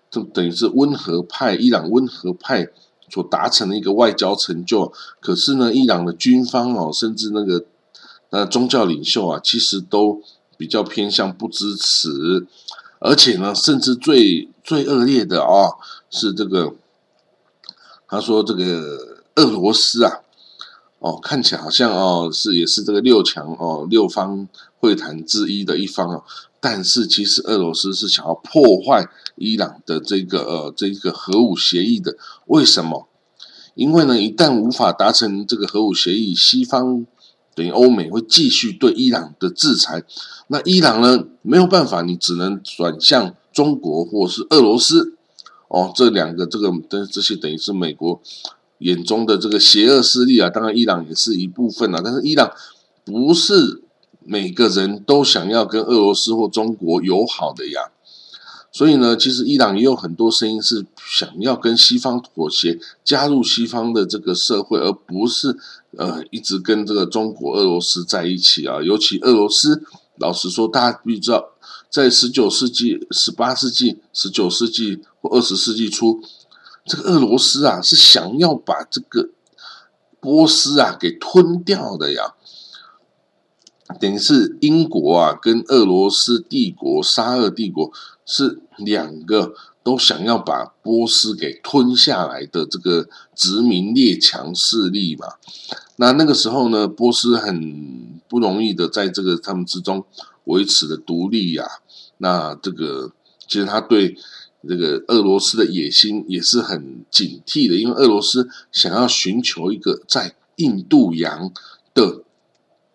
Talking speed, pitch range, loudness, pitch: 230 characters per minute, 95-130 Hz, -16 LUFS, 115 Hz